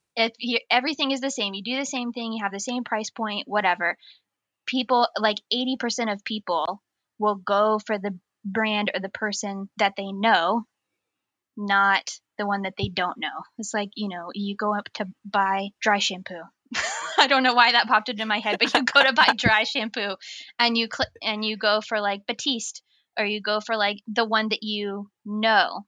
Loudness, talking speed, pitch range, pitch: -24 LUFS, 200 wpm, 205-235 Hz, 215 Hz